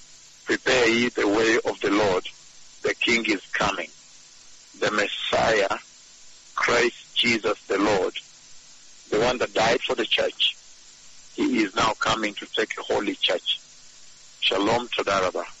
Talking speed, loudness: 140 wpm, -23 LUFS